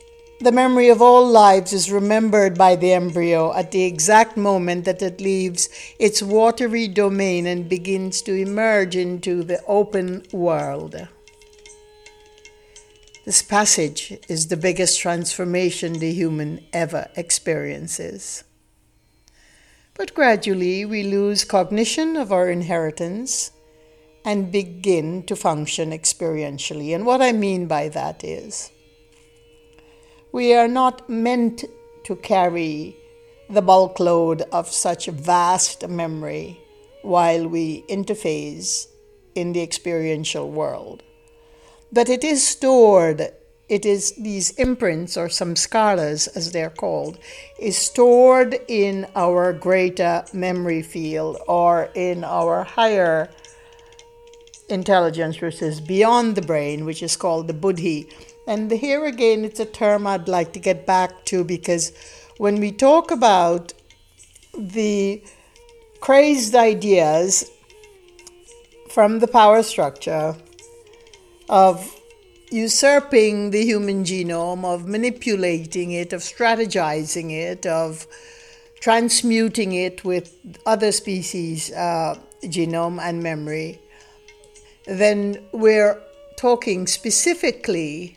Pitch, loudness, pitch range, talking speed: 195 Hz, -19 LUFS, 170-240 Hz, 110 wpm